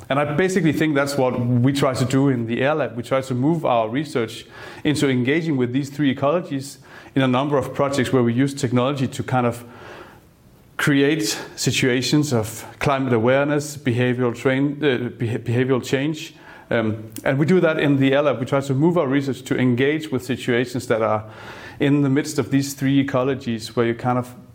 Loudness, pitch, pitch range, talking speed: -20 LUFS, 135 Hz, 125-145 Hz, 200 wpm